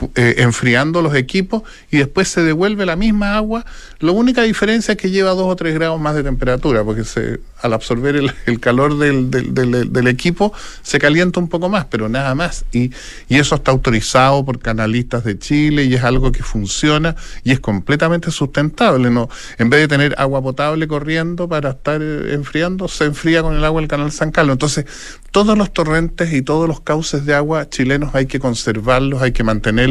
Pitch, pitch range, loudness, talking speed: 145 Hz, 125-165 Hz, -16 LUFS, 200 wpm